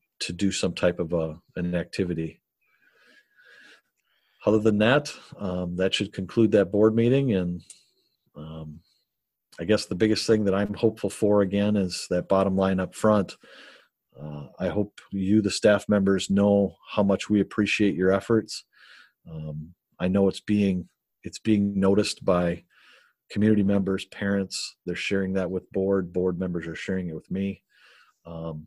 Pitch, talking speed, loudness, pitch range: 95 Hz, 155 wpm, -25 LUFS, 90-105 Hz